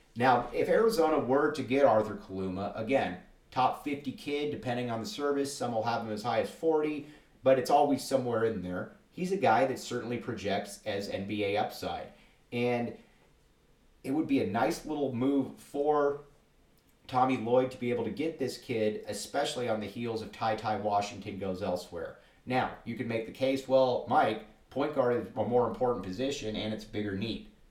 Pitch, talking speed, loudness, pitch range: 120 Hz, 185 wpm, -31 LUFS, 110-140 Hz